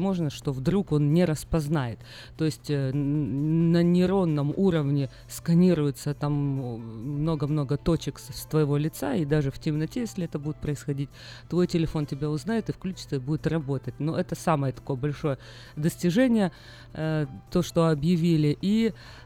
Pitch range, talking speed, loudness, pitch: 140-170 Hz, 145 wpm, -27 LUFS, 150 Hz